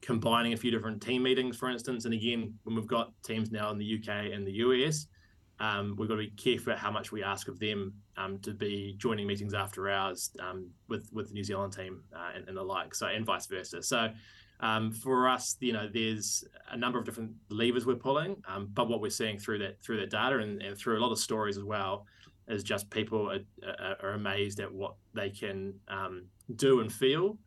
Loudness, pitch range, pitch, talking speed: -33 LUFS, 100-115 Hz, 110 Hz, 225 wpm